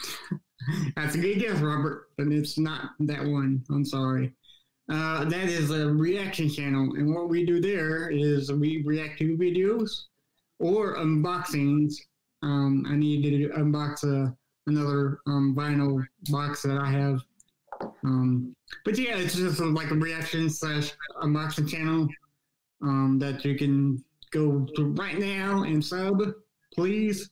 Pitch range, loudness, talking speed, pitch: 140-165 Hz, -27 LUFS, 145 wpm, 150 Hz